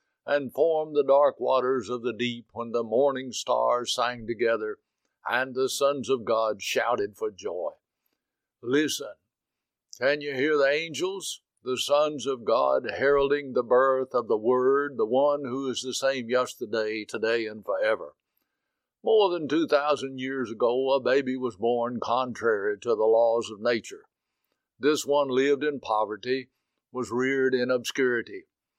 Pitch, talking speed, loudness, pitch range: 130 Hz, 150 wpm, -26 LUFS, 120-145 Hz